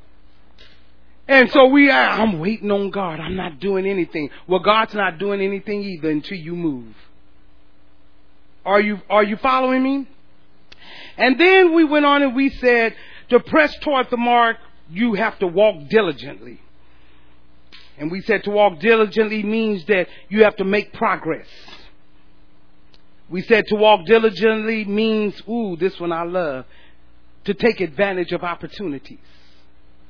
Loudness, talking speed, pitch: -18 LUFS, 150 wpm, 195 Hz